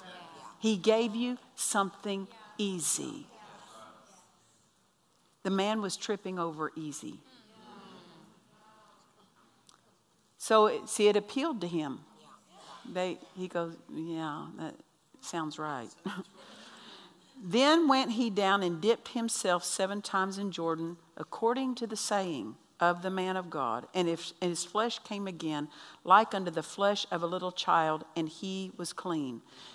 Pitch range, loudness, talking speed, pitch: 170-215 Hz, -31 LUFS, 130 wpm, 190 Hz